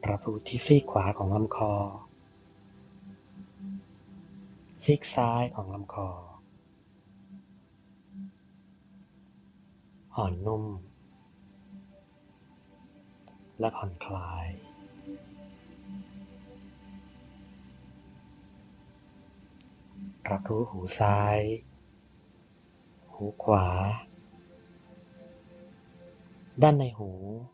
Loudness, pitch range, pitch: -29 LUFS, 95-115 Hz, 100 Hz